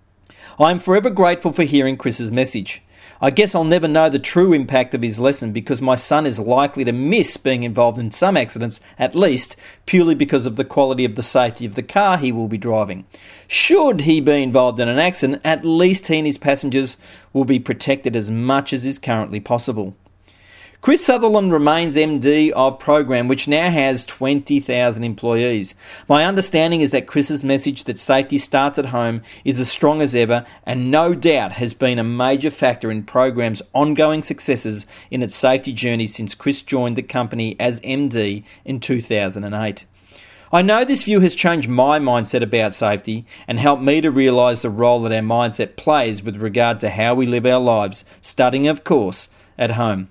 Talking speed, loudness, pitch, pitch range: 185 wpm, -17 LUFS, 130 Hz, 115-145 Hz